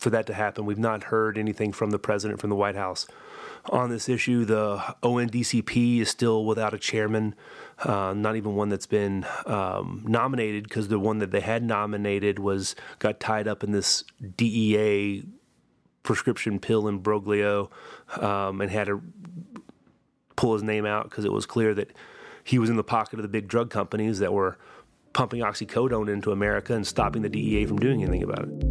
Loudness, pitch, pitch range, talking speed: -26 LUFS, 105 Hz, 105-115 Hz, 185 wpm